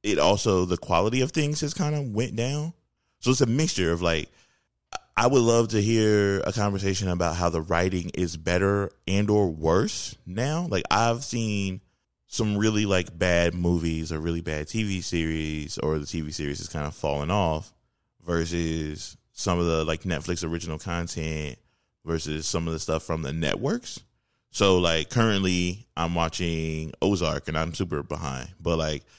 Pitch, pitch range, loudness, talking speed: 85 Hz, 80-100 Hz, -26 LUFS, 175 wpm